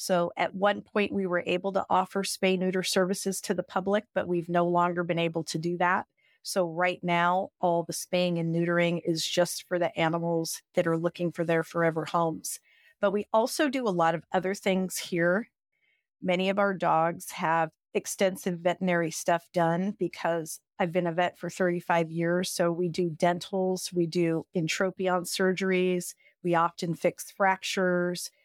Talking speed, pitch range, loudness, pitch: 175 wpm, 170-190 Hz, -28 LUFS, 180 Hz